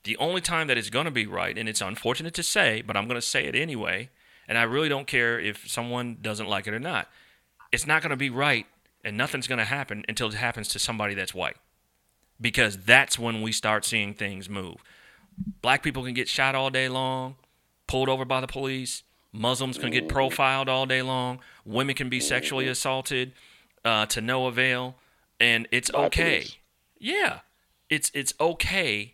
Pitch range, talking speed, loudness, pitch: 110-130 Hz, 185 wpm, -25 LUFS, 125 Hz